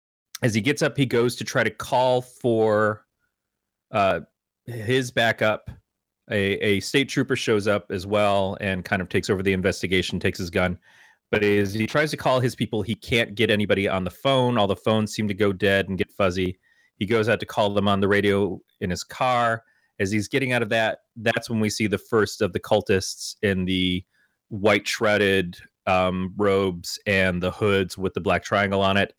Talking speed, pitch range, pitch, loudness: 205 wpm, 95-115 Hz, 100 Hz, -23 LUFS